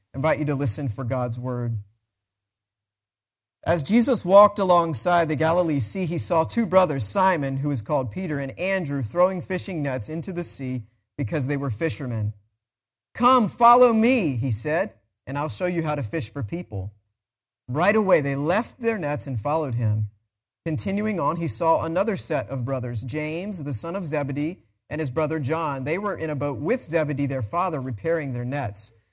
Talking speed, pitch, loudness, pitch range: 180 wpm, 145 Hz, -24 LUFS, 120-170 Hz